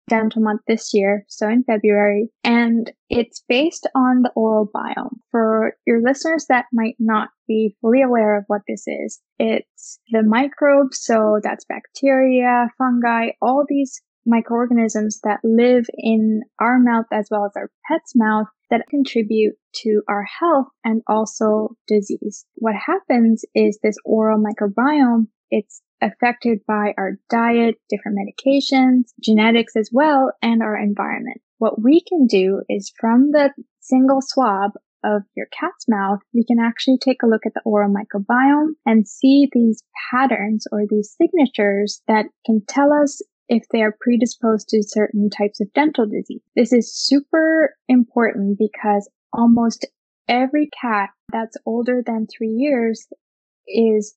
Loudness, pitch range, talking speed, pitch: -18 LUFS, 215-260 Hz, 150 wpm, 230 Hz